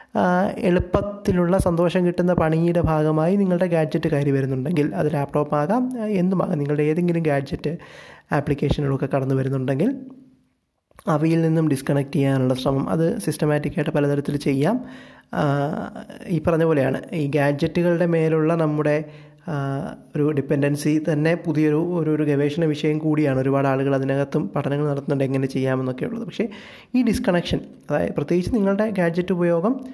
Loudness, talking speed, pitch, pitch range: -21 LUFS, 120 wpm, 155 Hz, 145-180 Hz